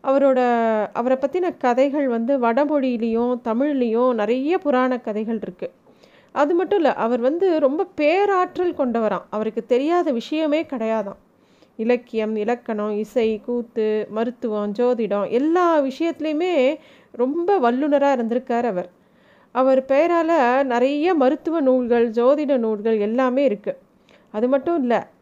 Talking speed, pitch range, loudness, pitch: 110 wpm, 230-290 Hz, -20 LUFS, 255 Hz